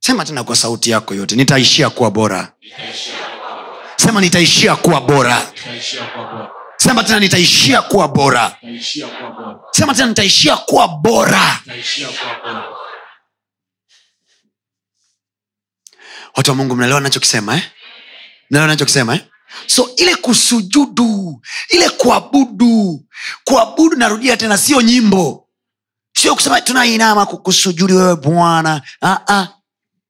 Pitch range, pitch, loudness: 140-230 Hz, 180 Hz, -12 LUFS